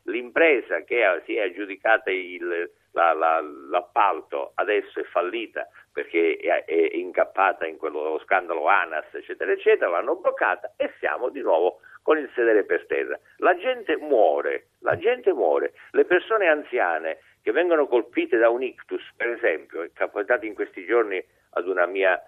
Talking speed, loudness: 150 wpm, -24 LUFS